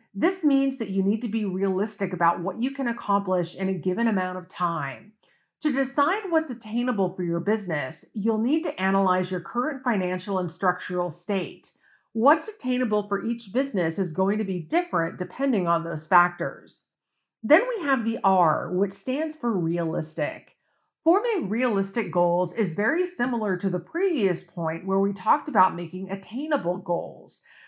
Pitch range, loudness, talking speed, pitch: 180-250 Hz, -25 LUFS, 165 wpm, 200 Hz